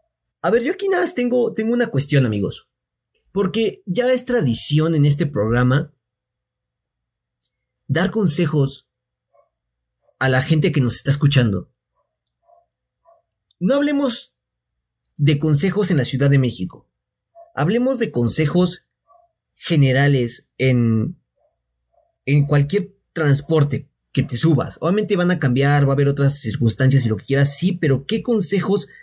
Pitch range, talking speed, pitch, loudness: 130-200 Hz, 135 wpm, 145 Hz, -18 LUFS